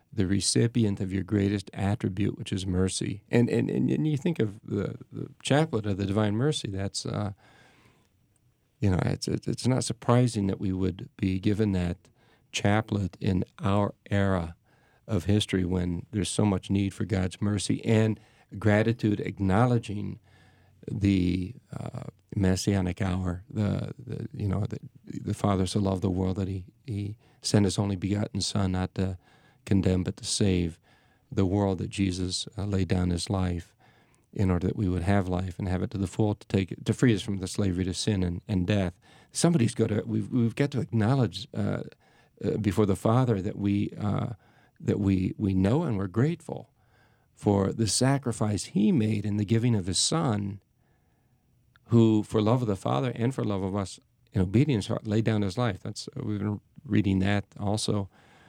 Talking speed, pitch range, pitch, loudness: 180 wpm, 95-120 Hz, 105 Hz, -28 LUFS